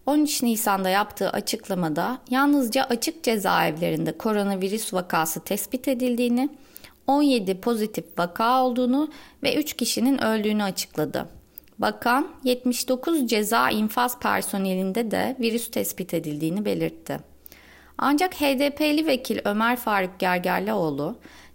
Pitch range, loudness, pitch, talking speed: 190-260 Hz, -24 LUFS, 230 Hz, 100 wpm